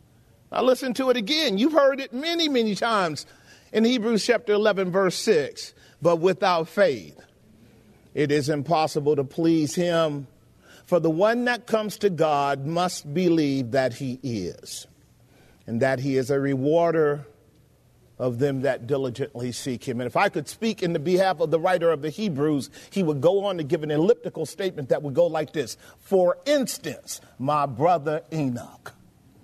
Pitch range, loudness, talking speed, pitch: 140-205 Hz, -24 LUFS, 170 wpm, 160 Hz